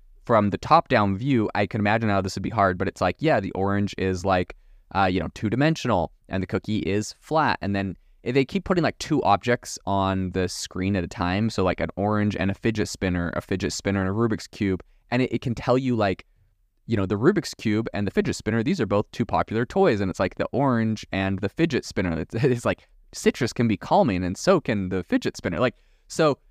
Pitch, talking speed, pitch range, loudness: 100 Hz, 240 wpm, 95-115 Hz, -24 LUFS